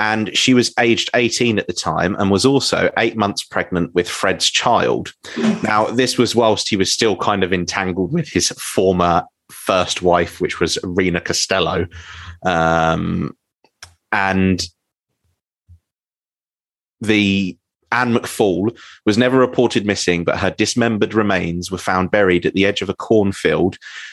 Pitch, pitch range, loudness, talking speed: 95 Hz, 90-110 Hz, -17 LUFS, 145 wpm